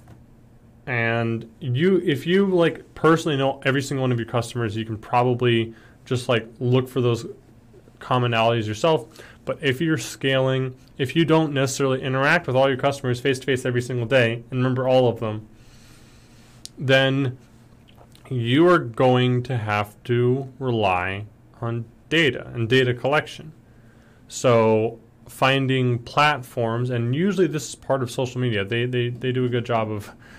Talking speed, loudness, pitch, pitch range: 155 wpm, -22 LUFS, 125 Hz, 115-135 Hz